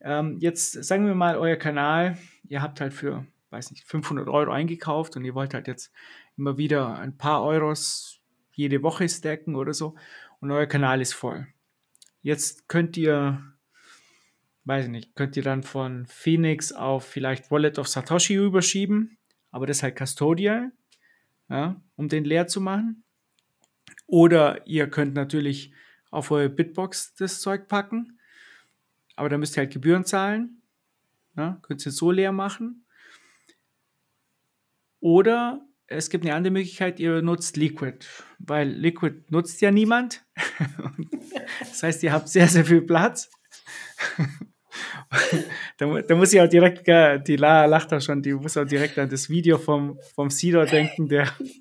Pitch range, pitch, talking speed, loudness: 145-180 Hz, 155 Hz, 150 wpm, -23 LUFS